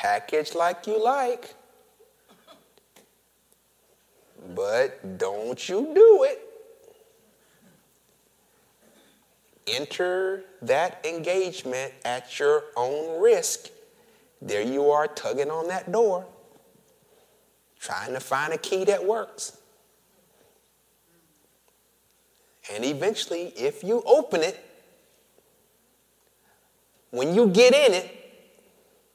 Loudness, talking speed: -24 LUFS, 85 wpm